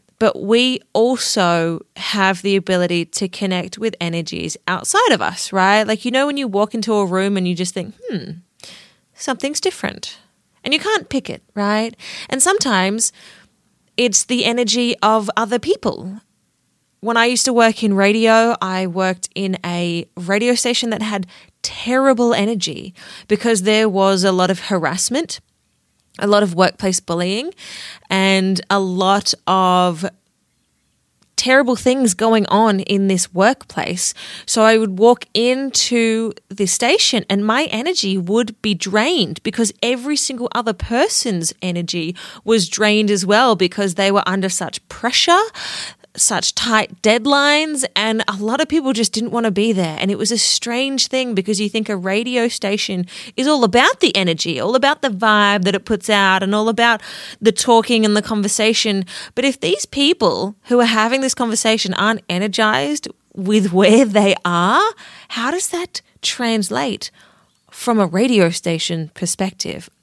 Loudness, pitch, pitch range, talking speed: -16 LUFS, 215 Hz, 190-240 Hz, 160 wpm